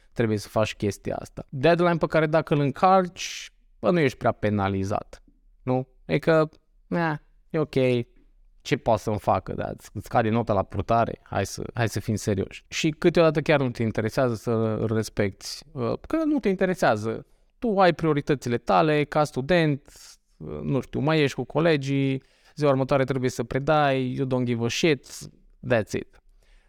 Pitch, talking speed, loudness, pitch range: 130 Hz, 165 wpm, -25 LUFS, 115-155 Hz